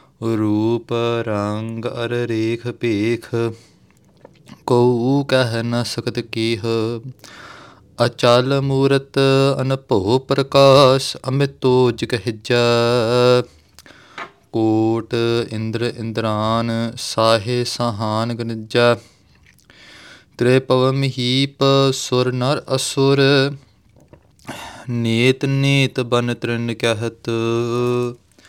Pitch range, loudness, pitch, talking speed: 115-130 Hz, -18 LUFS, 120 Hz, 75 wpm